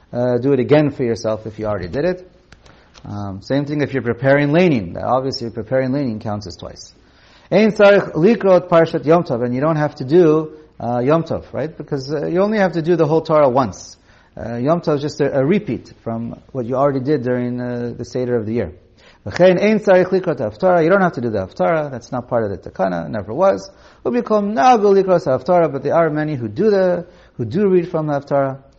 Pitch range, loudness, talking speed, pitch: 120-175 Hz, -17 LUFS, 215 wpm, 145 Hz